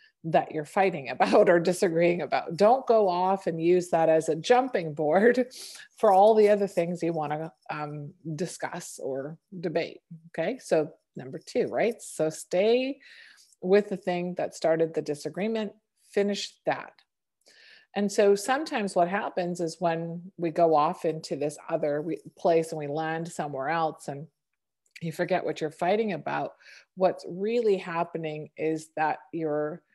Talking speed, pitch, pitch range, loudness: 155 wpm, 175 Hz, 160-200 Hz, -27 LUFS